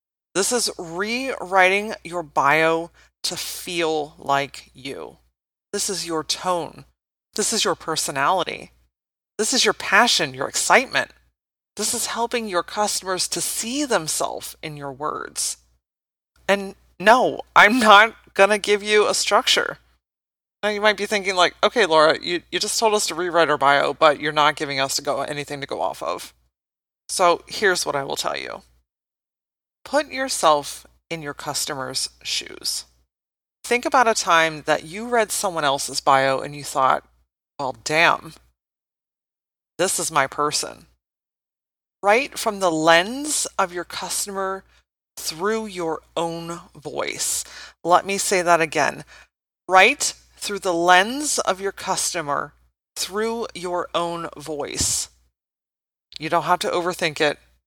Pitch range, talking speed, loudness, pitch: 145-205 Hz, 145 wpm, -20 LUFS, 170 Hz